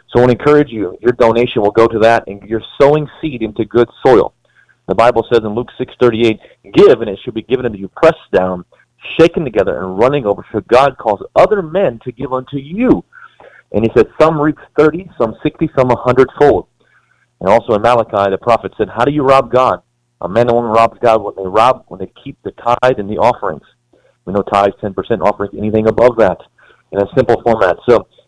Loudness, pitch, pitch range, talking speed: -13 LUFS, 120 Hz, 110-135 Hz, 215 wpm